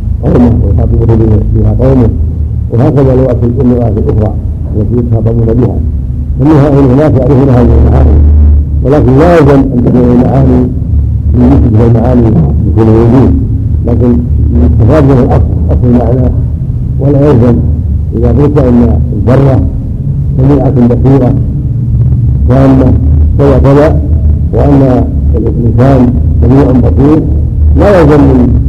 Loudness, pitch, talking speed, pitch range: -6 LUFS, 115 Hz, 100 wpm, 80-125 Hz